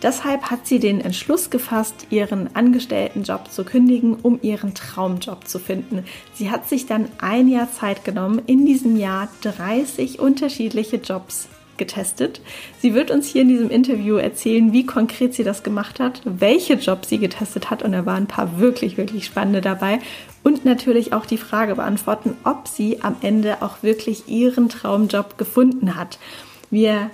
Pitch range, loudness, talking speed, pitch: 205-250 Hz, -19 LUFS, 170 wpm, 225 Hz